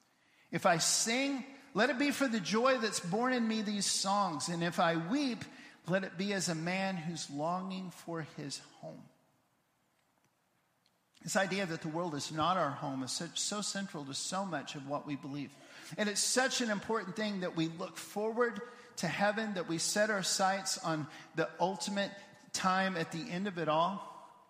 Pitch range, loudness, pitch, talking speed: 165-215 Hz, -34 LUFS, 190 Hz, 185 wpm